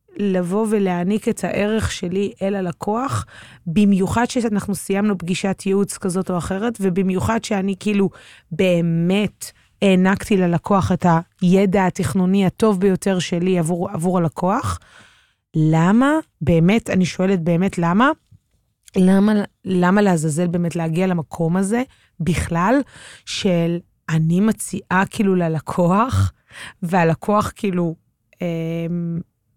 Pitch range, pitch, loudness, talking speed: 170-200 Hz, 185 Hz, -19 LUFS, 105 wpm